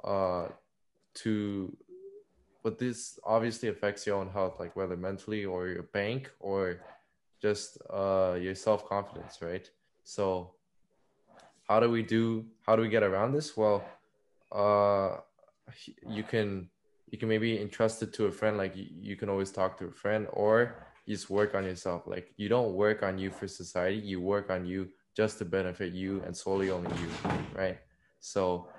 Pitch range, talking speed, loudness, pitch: 95-110 Hz, 170 wpm, -32 LUFS, 100 Hz